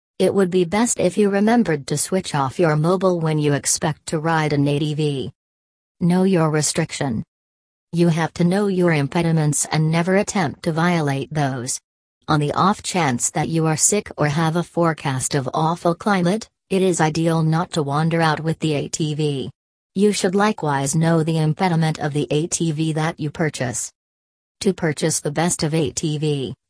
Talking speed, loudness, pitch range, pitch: 175 wpm, -20 LUFS, 145-175 Hz, 160 Hz